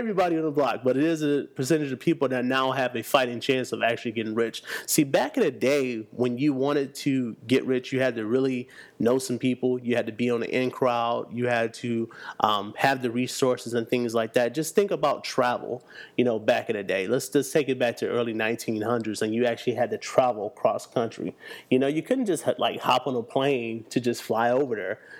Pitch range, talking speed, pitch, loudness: 115-135 Hz, 235 wpm, 125 Hz, -26 LUFS